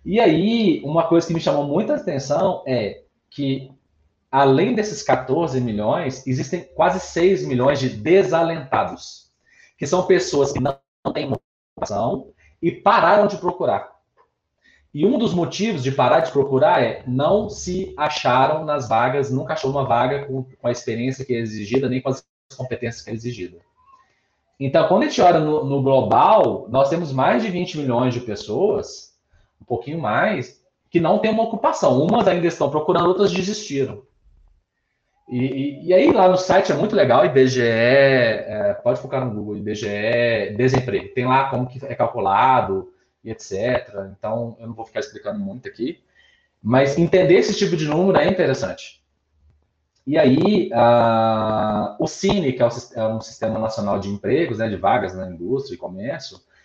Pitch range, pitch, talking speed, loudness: 120-180 Hz, 135 Hz, 165 wpm, -19 LUFS